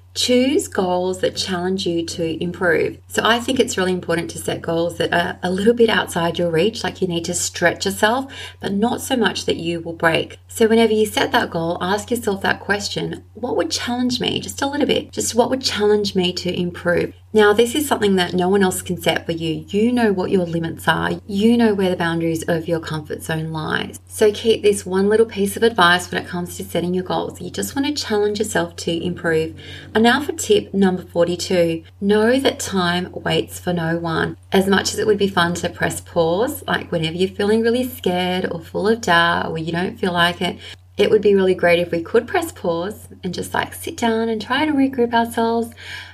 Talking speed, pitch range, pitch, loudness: 225 wpm, 170-225 Hz, 185 Hz, -19 LUFS